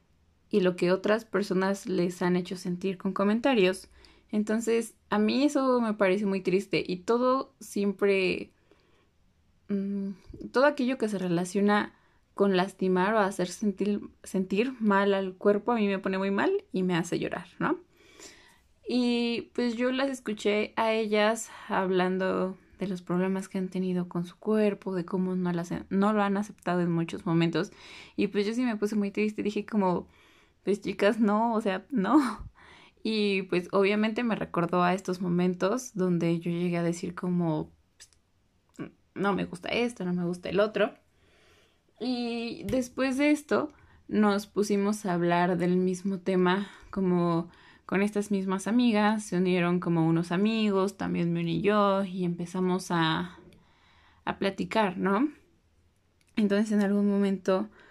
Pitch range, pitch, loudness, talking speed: 180-215 Hz, 195 Hz, -28 LUFS, 155 wpm